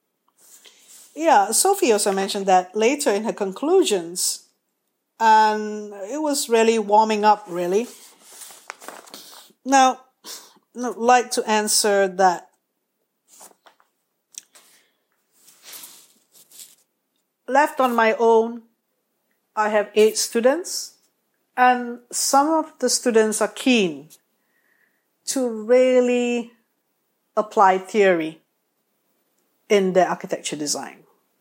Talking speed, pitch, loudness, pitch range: 85 wpm, 225 Hz, -19 LUFS, 205-250 Hz